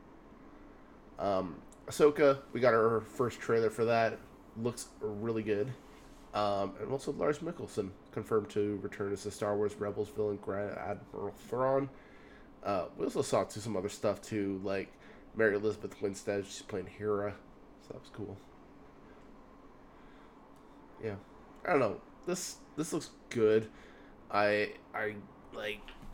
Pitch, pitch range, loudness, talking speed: 105 Hz, 100-115 Hz, -34 LUFS, 140 wpm